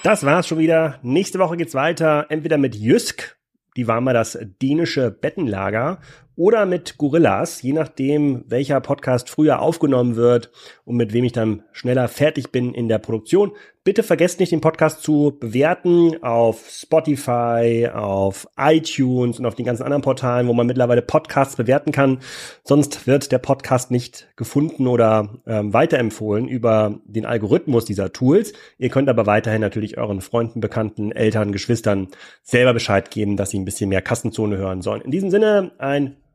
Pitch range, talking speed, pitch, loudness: 115-150 Hz, 165 wpm, 125 Hz, -19 LUFS